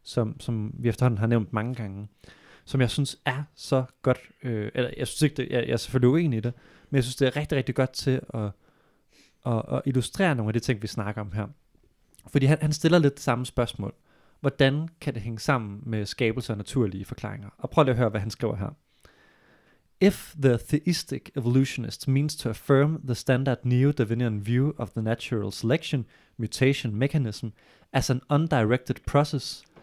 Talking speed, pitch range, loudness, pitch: 195 wpm, 115-140 Hz, -26 LUFS, 125 Hz